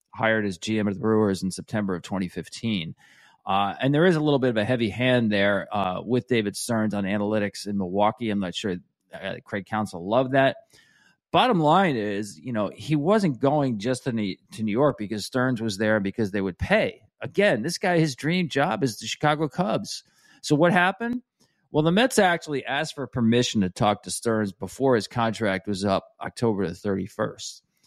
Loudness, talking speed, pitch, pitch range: -24 LUFS, 195 wpm, 110 Hz, 100-145 Hz